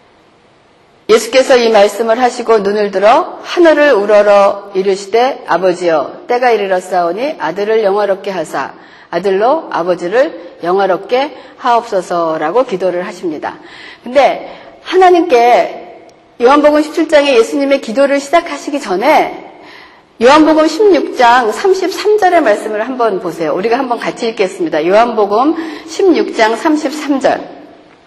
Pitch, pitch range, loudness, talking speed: 250 Hz, 205-330 Hz, -11 LUFS, 275 characters per minute